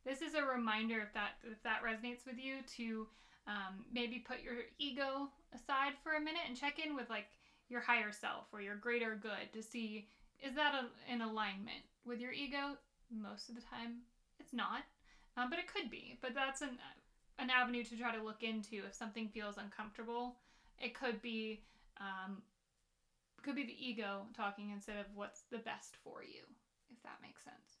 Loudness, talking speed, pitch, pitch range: -43 LUFS, 190 wpm, 240 Hz, 220-260 Hz